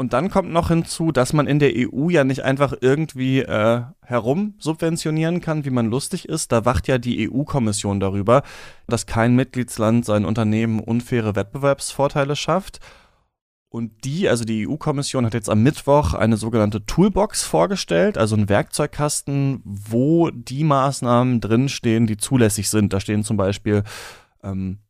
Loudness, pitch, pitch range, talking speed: -20 LUFS, 125 Hz, 110-145 Hz, 155 wpm